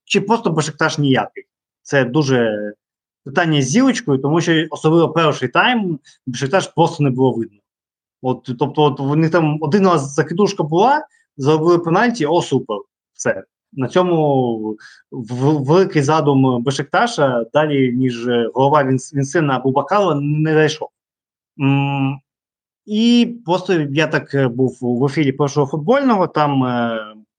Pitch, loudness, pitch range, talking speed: 150 Hz, -16 LUFS, 130-170 Hz, 130 wpm